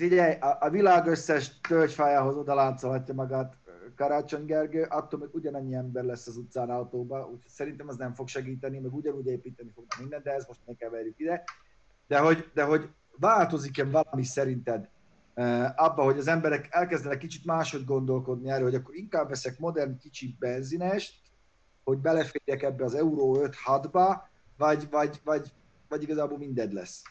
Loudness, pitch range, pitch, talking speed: -29 LUFS, 130-155 Hz, 140 Hz, 155 wpm